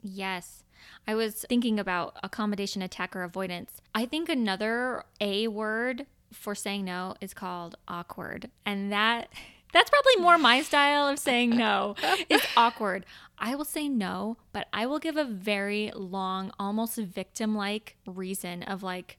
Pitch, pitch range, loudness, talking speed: 215 Hz, 195-245 Hz, -28 LUFS, 150 wpm